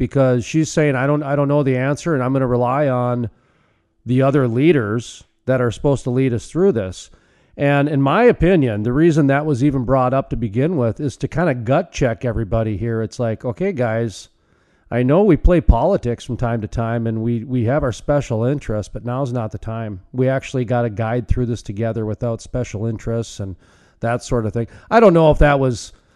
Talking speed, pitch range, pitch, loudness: 220 wpm, 115-140 Hz, 125 Hz, -18 LUFS